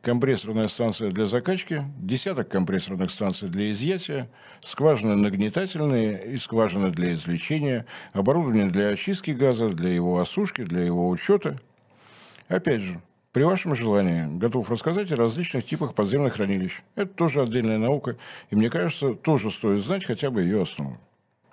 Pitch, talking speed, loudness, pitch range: 115 Hz, 140 wpm, -25 LUFS, 100-150 Hz